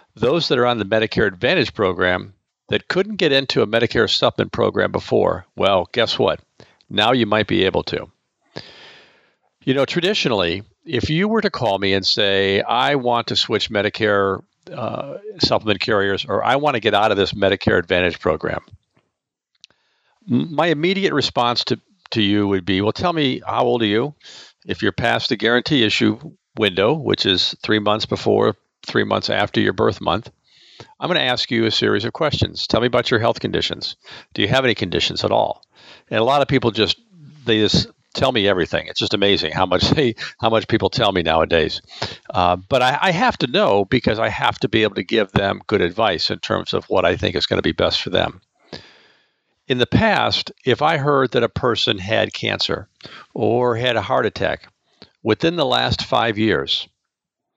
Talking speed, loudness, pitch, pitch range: 195 wpm, -18 LUFS, 115 Hz, 100-135 Hz